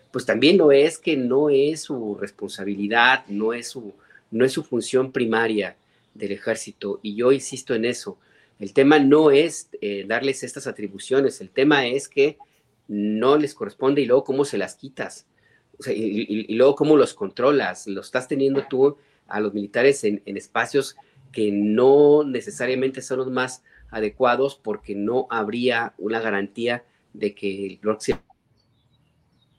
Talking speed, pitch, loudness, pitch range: 160 wpm, 120 Hz, -21 LUFS, 105-135 Hz